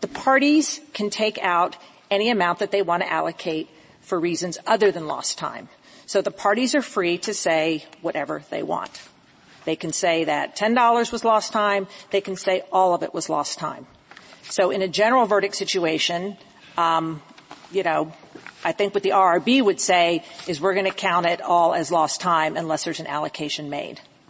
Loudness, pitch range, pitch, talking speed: -22 LUFS, 165-205 Hz, 185 Hz, 190 wpm